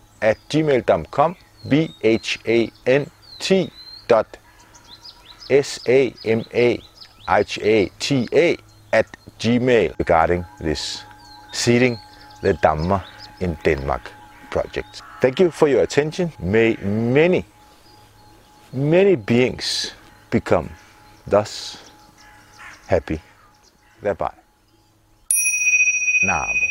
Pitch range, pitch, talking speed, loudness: 105-145 Hz, 110 Hz, 90 wpm, -19 LUFS